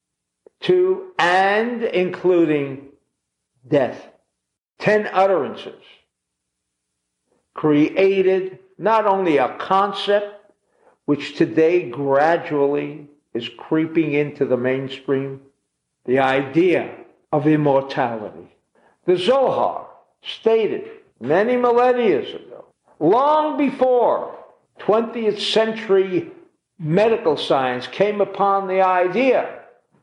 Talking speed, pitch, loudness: 80 wpm, 190 Hz, -19 LUFS